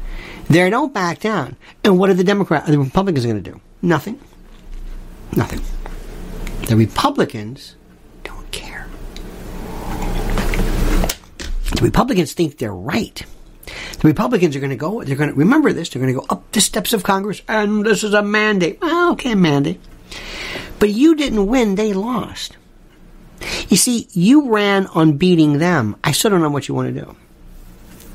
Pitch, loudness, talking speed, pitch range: 175 Hz, -17 LUFS, 160 wpm, 130-210 Hz